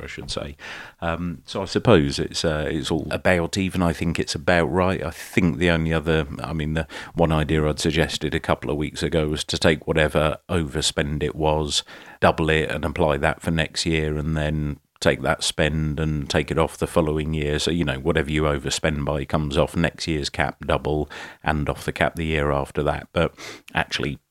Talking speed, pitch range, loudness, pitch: 210 wpm, 75-85 Hz, -23 LUFS, 80 Hz